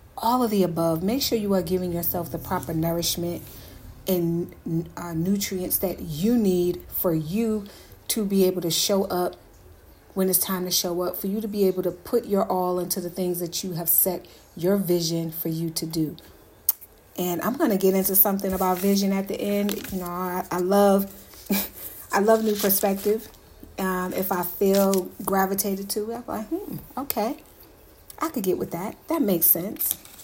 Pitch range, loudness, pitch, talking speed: 175-200 Hz, -24 LUFS, 185 Hz, 190 wpm